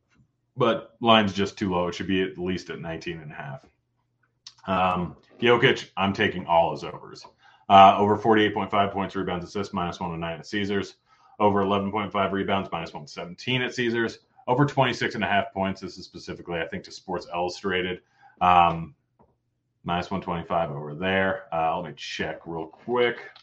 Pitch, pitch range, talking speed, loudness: 95 Hz, 90-110 Hz, 165 wpm, -24 LUFS